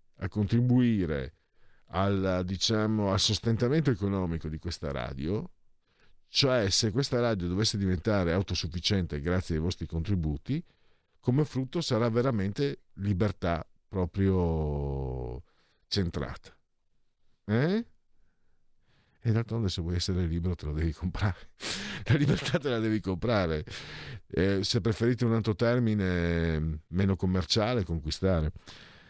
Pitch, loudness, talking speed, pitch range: 95 Hz, -29 LUFS, 110 wpm, 85-115 Hz